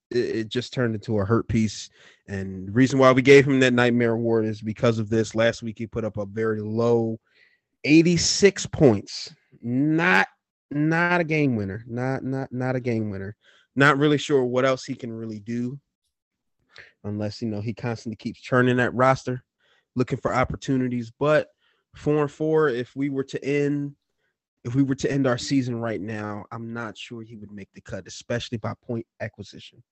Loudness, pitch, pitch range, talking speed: -23 LUFS, 120 Hz, 110-135 Hz, 185 wpm